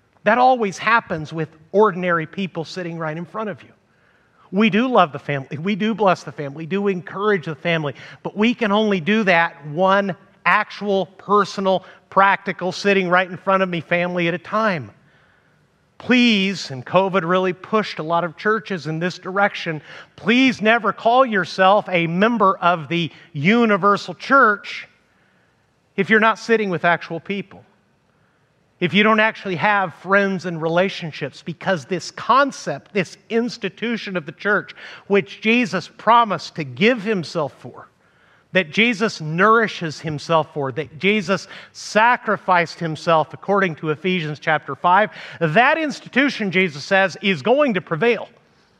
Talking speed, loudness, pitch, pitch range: 150 wpm, -19 LUFS, 185 Hz, 165-210 Hz